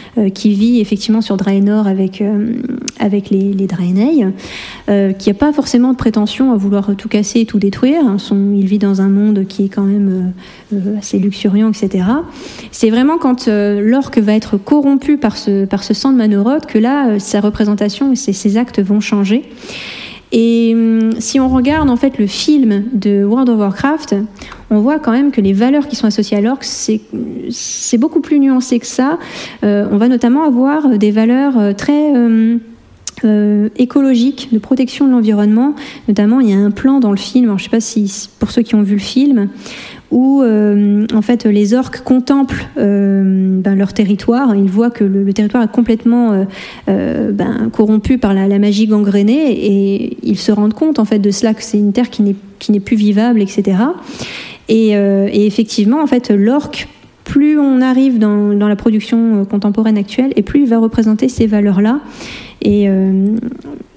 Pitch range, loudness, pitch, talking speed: 205-255 Hz, -12 LUFS, 220 Hz, 195 wpm